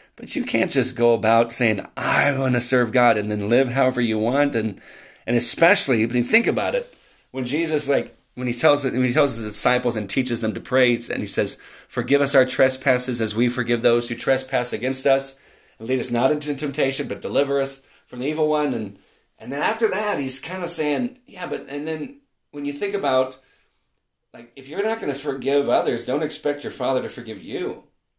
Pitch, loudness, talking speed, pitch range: 130 Hz, -21 LUFS, 215 wpm, 120-145 Hz